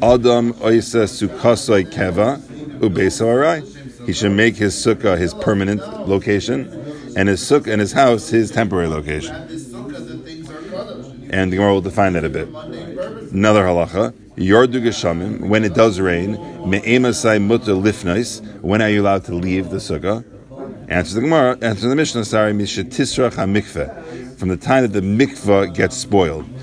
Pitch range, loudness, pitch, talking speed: 95-120 Hz, -17 LUFS, 105 Hz, 150 wpm